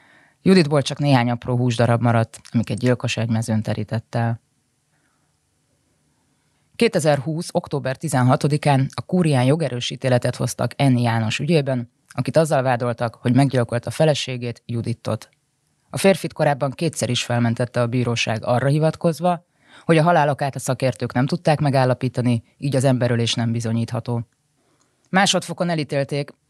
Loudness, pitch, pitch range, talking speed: -20 LUFS, 130 Hz, 120-150 Hz, 125 wpm